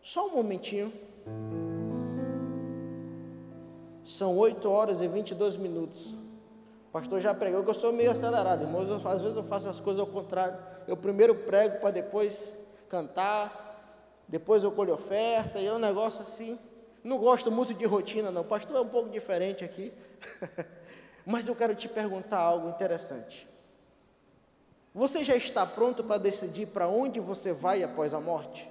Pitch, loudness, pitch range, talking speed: 205 Hz, -30 LUFS, 180-220 Hz, 160 wpm